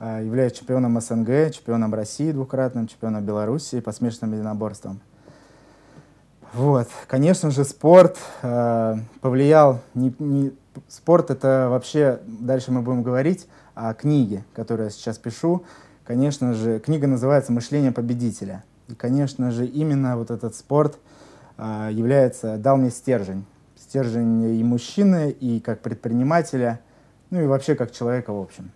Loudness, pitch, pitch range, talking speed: -21 LUFS, 125 Hz, 115-140 Hz, 130 wpm